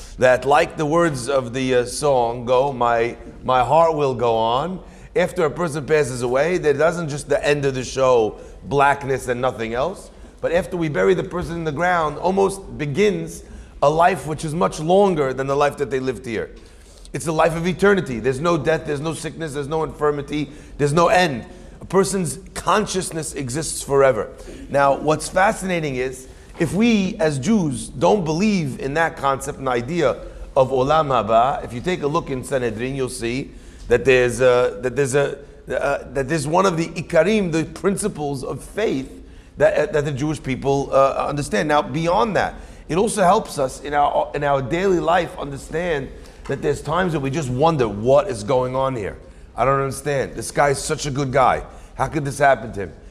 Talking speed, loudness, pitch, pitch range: 195 wpm, -20 LUFS, 145 Hz, 130-170 Hz